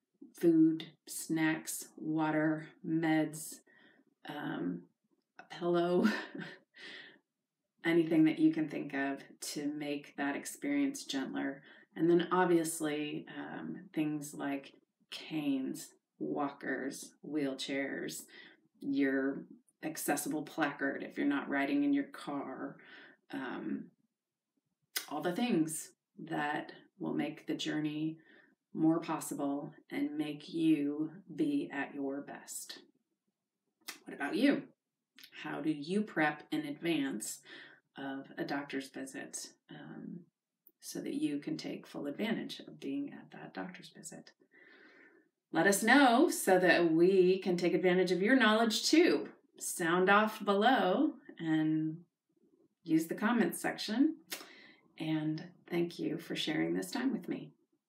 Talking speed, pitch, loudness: 115 wpm, 180 Hz, -34 LUFS